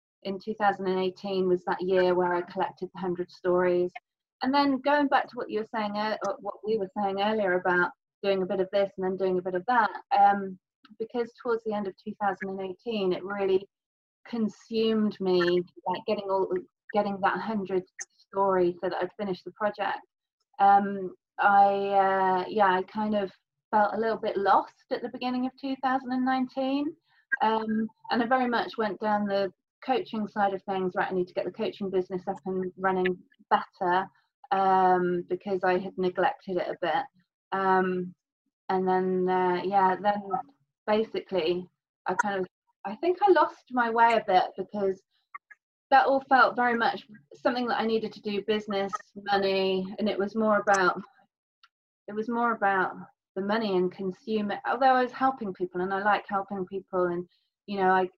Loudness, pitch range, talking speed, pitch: -27 LUFS, 185-225 Hz, 175 wpm, 200 Hz